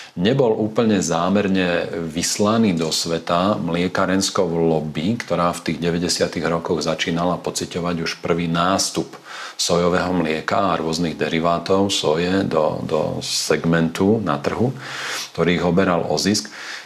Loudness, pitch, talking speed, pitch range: -20 LUFS, 85 Hz, 120 wpm, 85-95 Hz